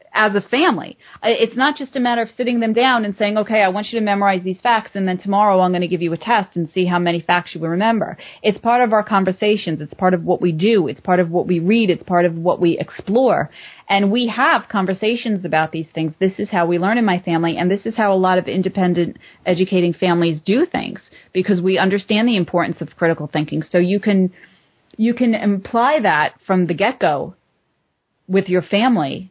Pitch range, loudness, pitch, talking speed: 175-215 Hz, -17 LUFS, 190 Hz, 225 wpm